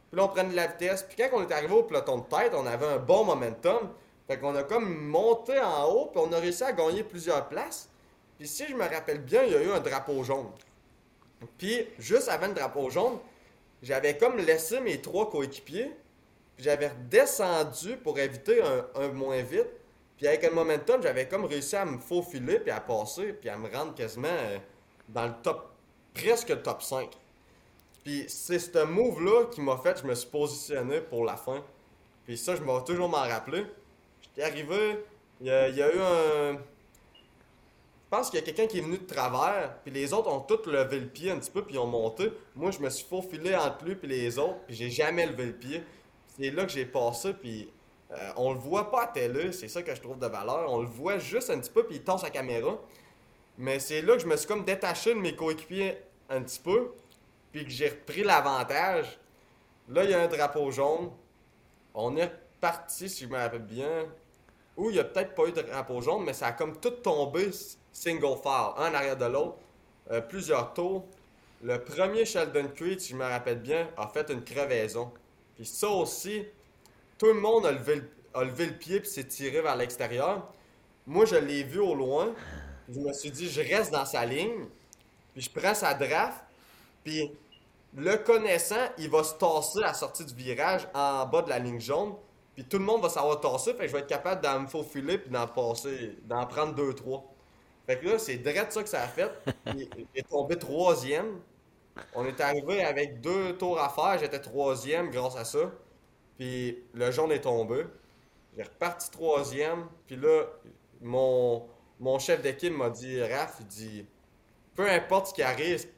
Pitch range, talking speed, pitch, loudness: 135-210 Hz, 210 wpm, 160 Hz, -30 LUFS